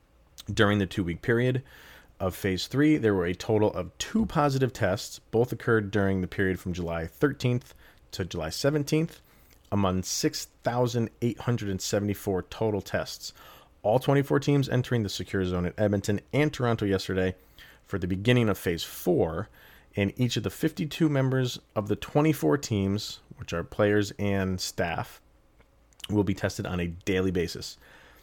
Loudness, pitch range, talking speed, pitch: -28 LUFS, 95-125 Hz, 150 wpm, 105 Hz